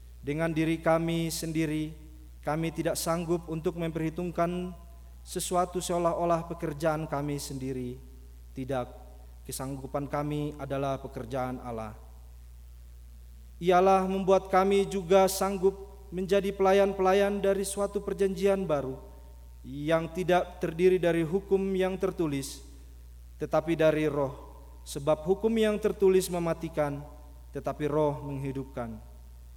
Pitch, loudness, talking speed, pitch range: 155 Hz, -29 LUFS, 100 wpm, 125-185 Hz